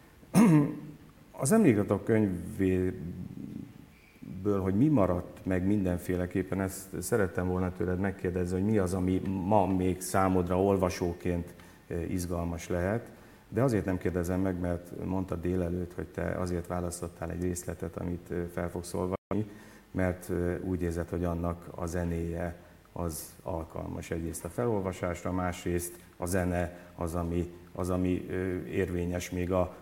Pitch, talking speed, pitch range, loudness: 90 Hz, 130 wpm, 85-95 Hz, -31 LUFS